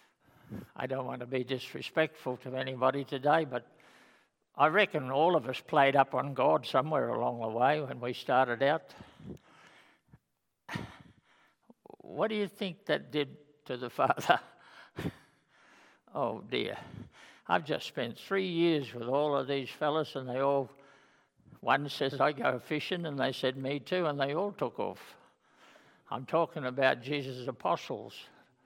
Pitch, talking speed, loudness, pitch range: 140 Hz, 150 wpm, -32 LUFS, 130-155 Hz